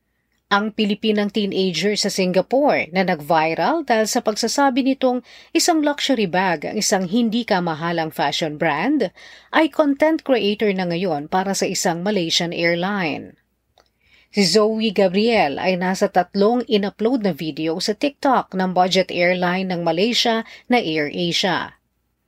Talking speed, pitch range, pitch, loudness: 130 wpm, 180-230 Hz, 200 Hz, -19 LUFS